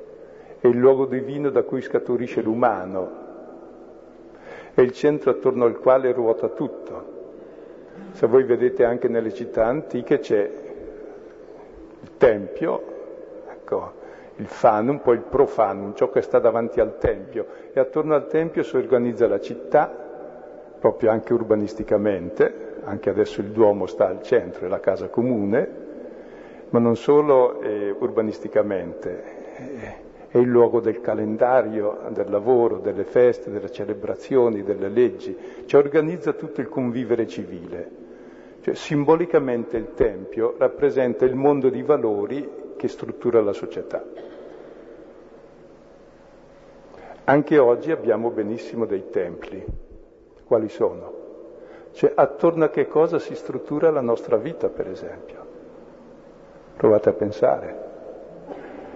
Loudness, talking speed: -21 LUFS, 125 wpm